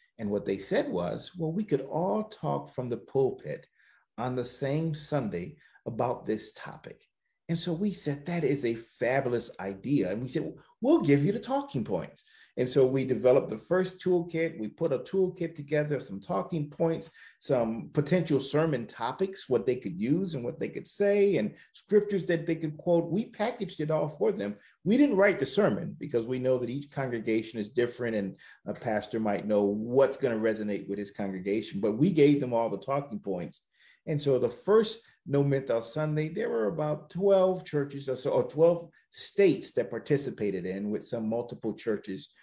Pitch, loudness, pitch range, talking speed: 150 Hz, -29 LUFS, 120-180 Hz, 190 wpm